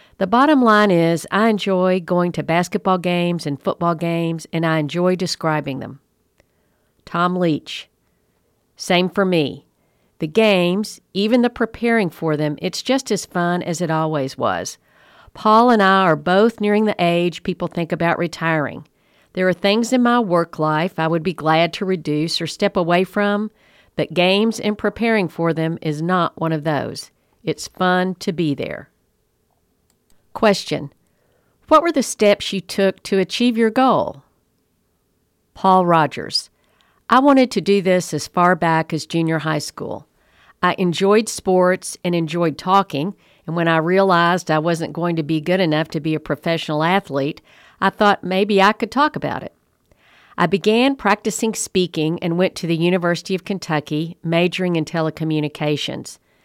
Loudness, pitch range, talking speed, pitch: -18 LUFS, 160-200 Hz, 160 wpm, 180 Hz